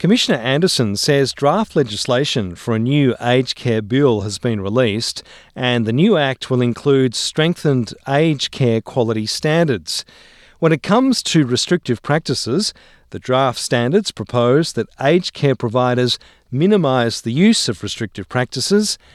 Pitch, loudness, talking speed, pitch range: 130 Hz, -17 LUFS, 140 wpm, 115-155 Hz